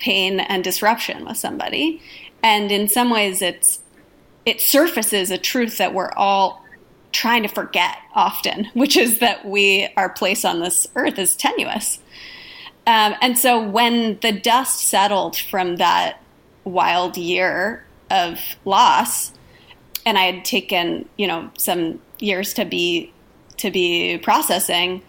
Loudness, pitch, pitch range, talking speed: -18 LUFS, 205 Hz, 185-240 Hz, 140 wpm